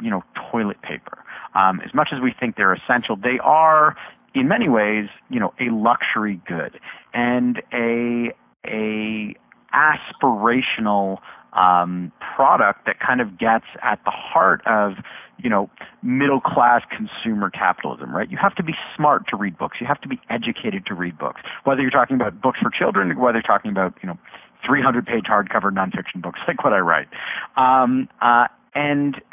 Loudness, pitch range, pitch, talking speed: -20 LUFS, 105-130 Hz, 120 Hz, 170 wpm